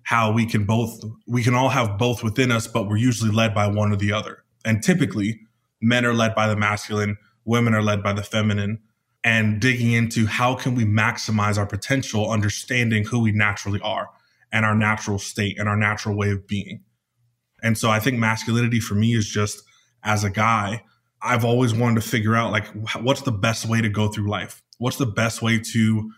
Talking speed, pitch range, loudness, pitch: 205 wpm, 105-120 Hz, -21 LUFS, 110 Hz